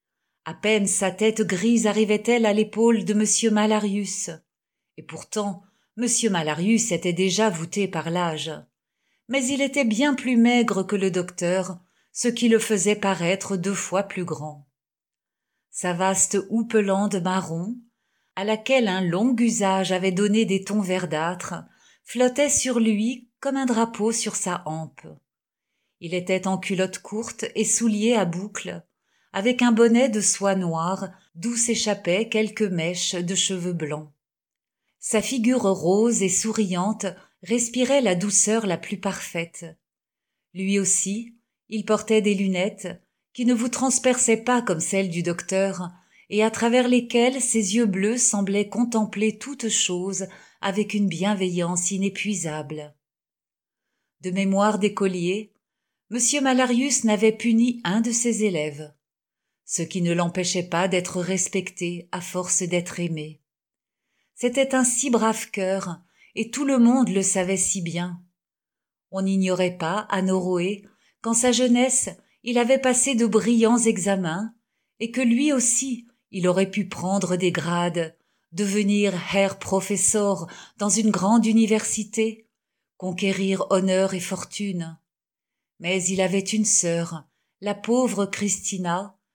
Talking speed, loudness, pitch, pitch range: 135 wpm, -22 LUFS, 200 Hz, 185-225 Hz